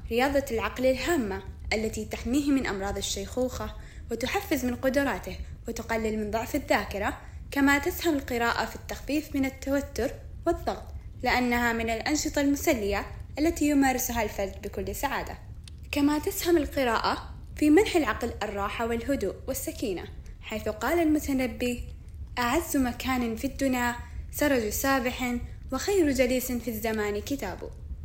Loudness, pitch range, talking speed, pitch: -28 LUFS, 230-290 Hz, 120 wpm, 260 Hz